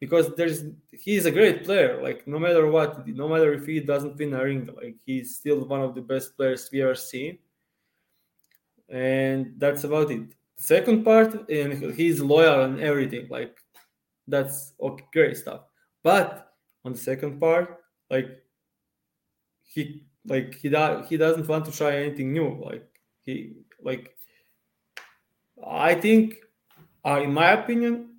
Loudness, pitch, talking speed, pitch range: -24 LUFS, 150 Hz, 150 wpm, 135-170 Hz